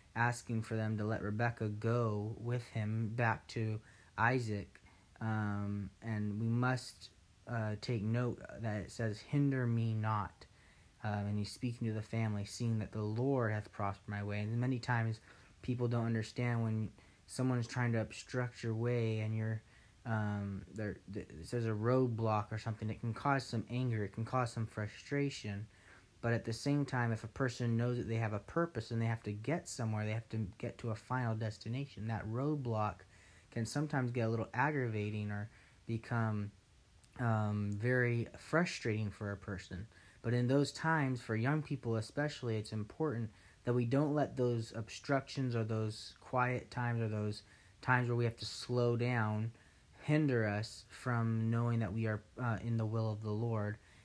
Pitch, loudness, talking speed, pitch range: 115 Hz, -38 LUFS, 180 wpm, 105-120 Hz